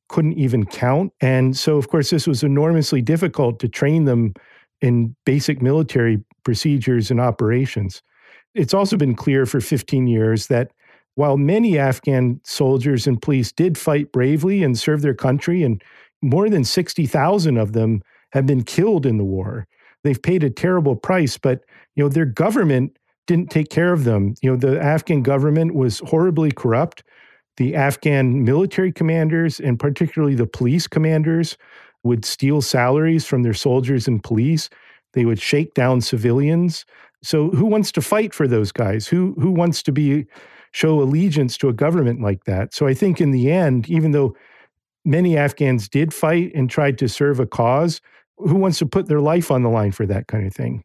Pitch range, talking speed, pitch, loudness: 125-160 Hz, 180 wpm, 140 Hz, -18 LUFS